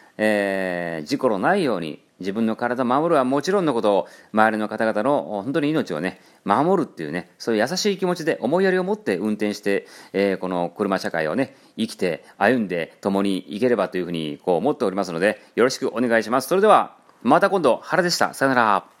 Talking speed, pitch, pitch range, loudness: 420 characters per minute, 110 Hz, 100-145 Hz, -22 LUFS